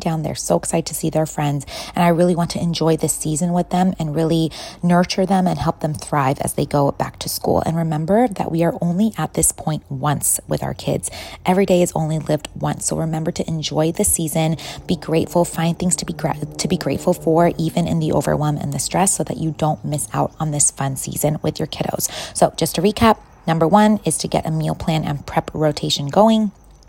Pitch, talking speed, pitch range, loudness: 165 Hz, 230 wpm, 155-175 Hz, -19 LUFS